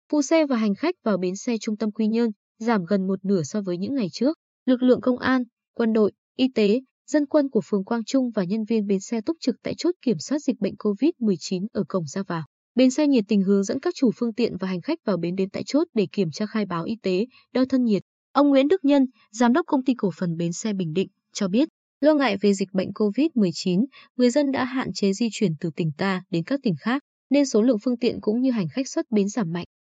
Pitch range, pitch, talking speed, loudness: 195-260 Hz, 225 Hz, 260 wpm, -24 LUFS